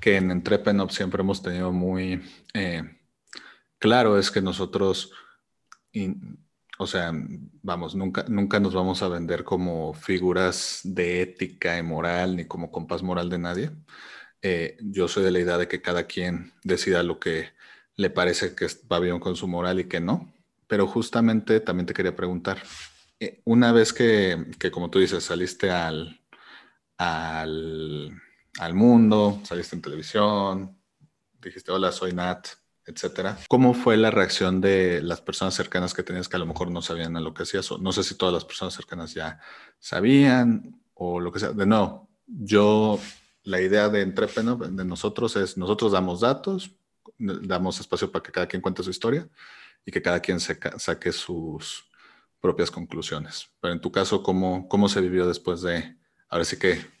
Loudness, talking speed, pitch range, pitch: -25 LUFS, 170 wpm, 90-105 Hz, 95 Hz